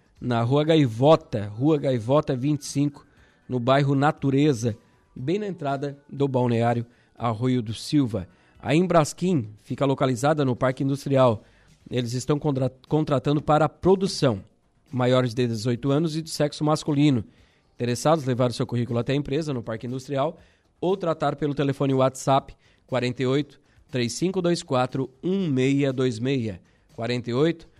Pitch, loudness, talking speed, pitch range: 135 Hz, -24 LUFS, 130 wpm, 125-150 Hz